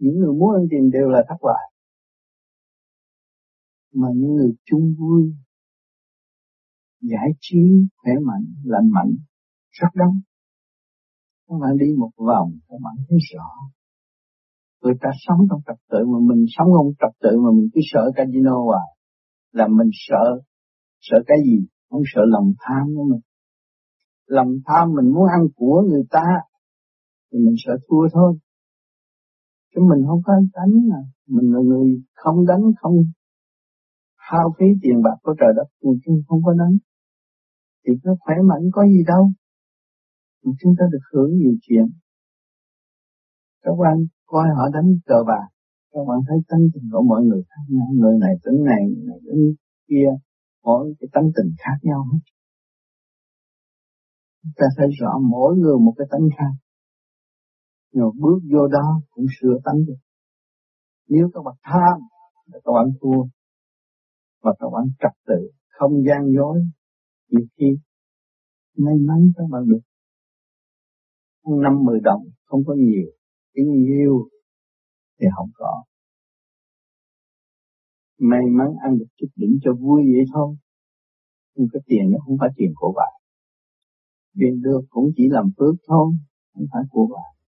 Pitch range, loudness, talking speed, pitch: 130-185 Hz, -17 LUFS, 155 wpm, 150 Hz